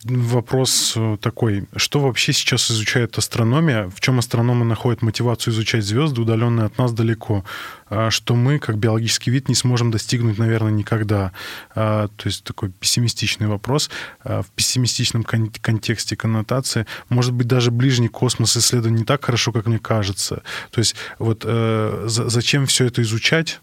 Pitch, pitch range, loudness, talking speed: 115 Hz, 110-125 Hz, -19 LUFS, 140 wpm